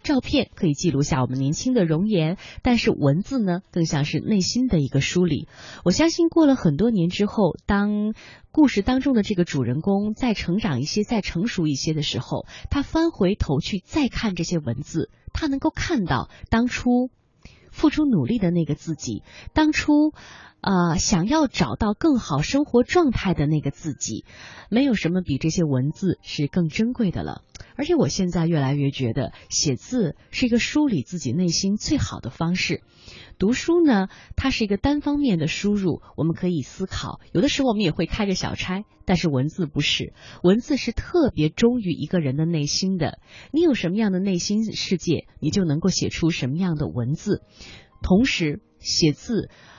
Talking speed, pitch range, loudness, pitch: 275 characters per minute, 155-235 Hz, -22 LUFS, 185 Hz